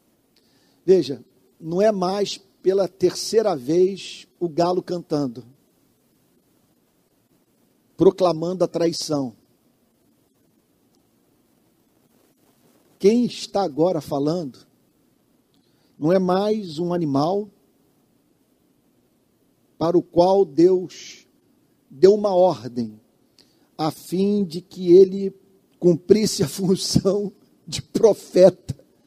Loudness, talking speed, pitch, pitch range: -20 LUFS, 80 wpm, 180 Hz, 165-195 Hz